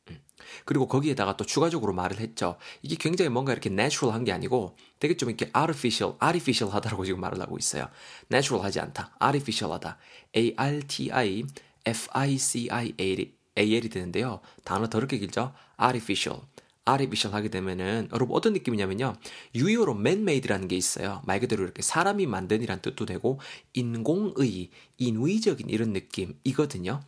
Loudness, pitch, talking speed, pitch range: -28 LUFS, 115 Hz, 450 characters per minute, 100-135 Hz